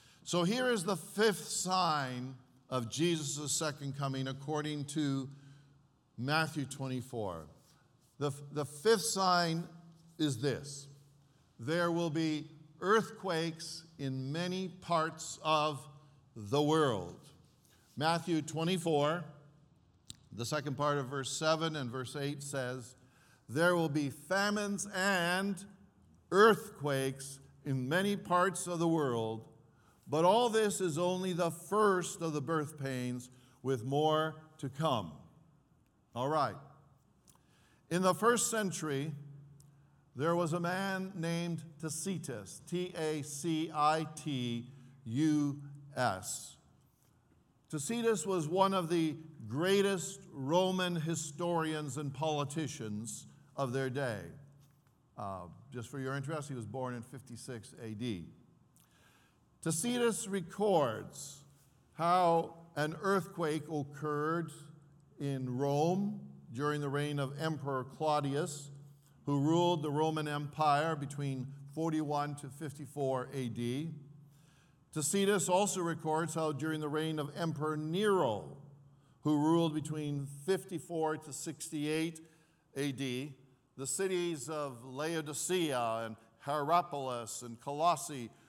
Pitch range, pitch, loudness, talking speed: 140-165 Hz, 150 Hz, -35 LUFS, 110 wpm